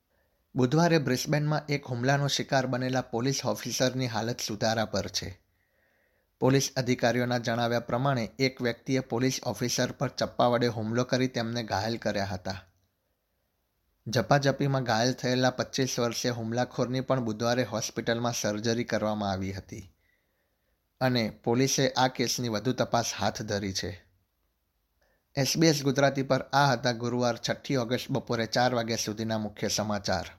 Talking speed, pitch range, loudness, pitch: 130 wpm, 105-130 Hz, -28 LUFS, 120 Hz